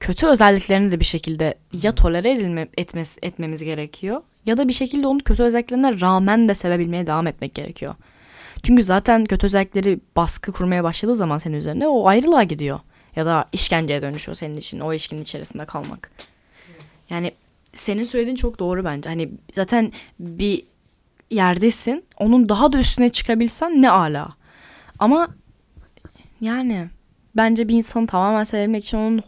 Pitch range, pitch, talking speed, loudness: 165-235 Hz, 195 Hz, 150 wpm, -19 LUFS